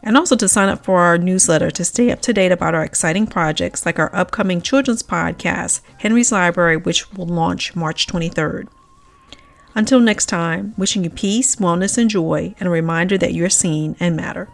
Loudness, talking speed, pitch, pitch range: -16 LUFS, 190 wpm, 180 Hz, 170-210 Hz